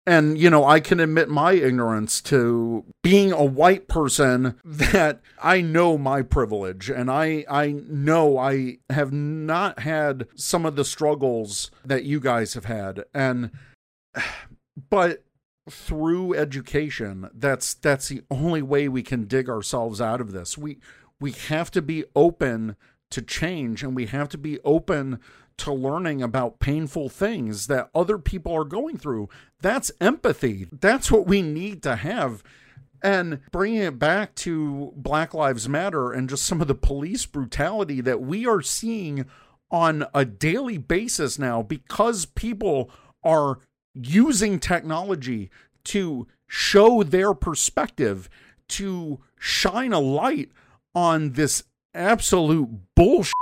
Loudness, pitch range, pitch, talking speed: -23 LUFS, 130-170 Hz, 145 Hz, 140 wpm